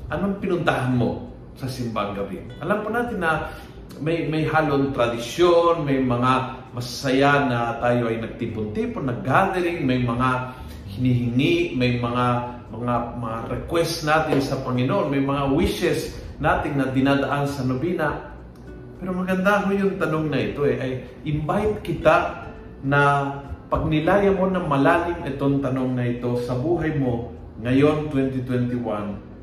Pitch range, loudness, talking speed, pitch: 120-160 Hz, -22 LUFS, 135 wpm, 135 Hz